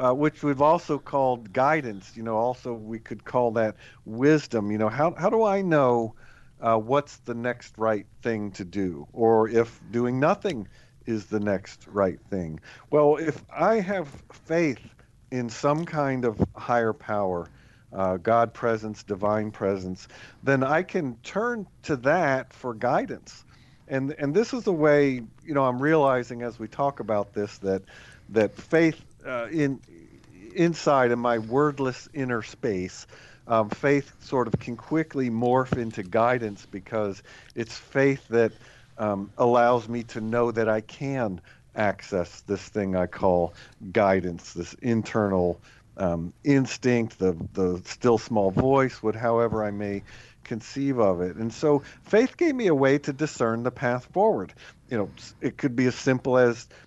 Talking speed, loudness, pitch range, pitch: 160 wpm, -25 LUFS, 110-140 Hz, 120 Hz